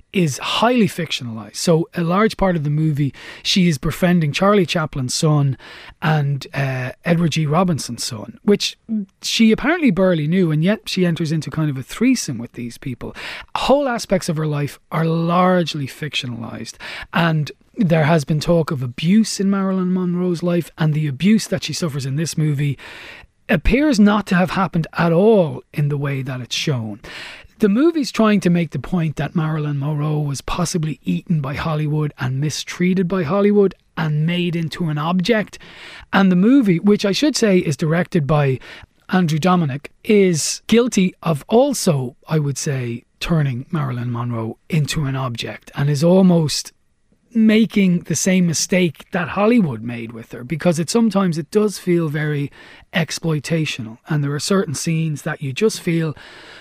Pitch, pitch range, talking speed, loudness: 165 Hz, 145-190 Hz, 165 wpm, -18 LUFS